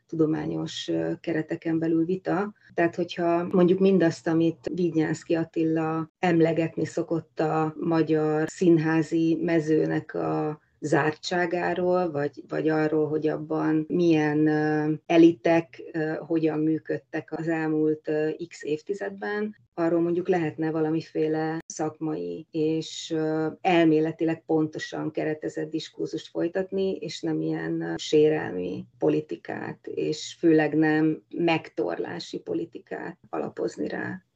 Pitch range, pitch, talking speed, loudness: 155-165 Hz, 160 Hz, 105 wpm, -26 LUFS